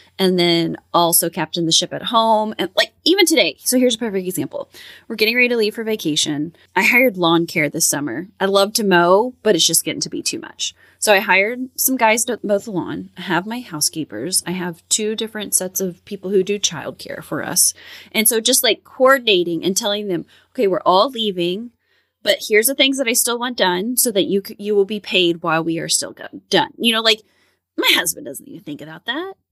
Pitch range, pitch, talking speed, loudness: 175-235 Hz, 205 Hz, 230 wpm, -17 LUFS